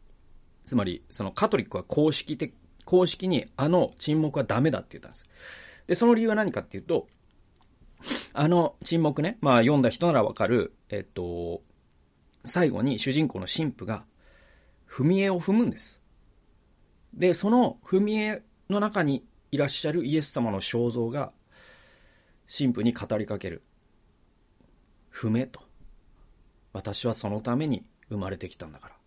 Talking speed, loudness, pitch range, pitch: 280 characters per minute, -27 LUFS, 100-170 Hz, 135 Hz